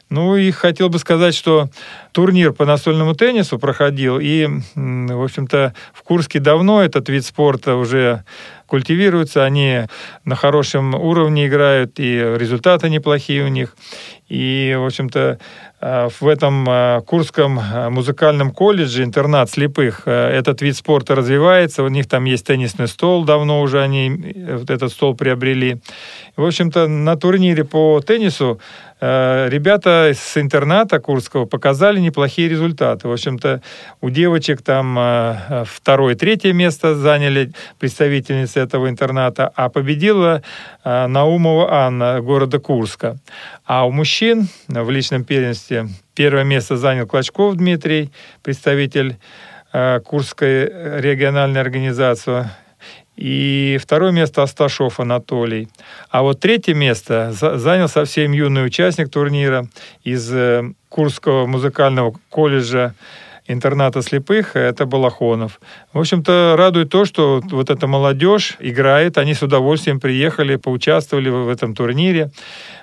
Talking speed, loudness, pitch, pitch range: 120 wpm, -15 LUFS, 140 Hz, 130-155 Hz